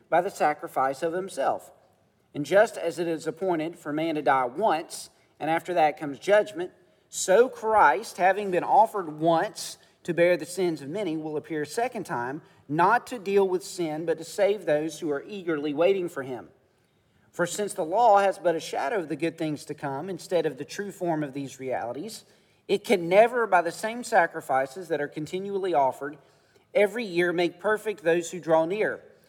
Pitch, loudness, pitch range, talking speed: 170 Hz, -26 LUFS, 155-200 Hz, 195 wpm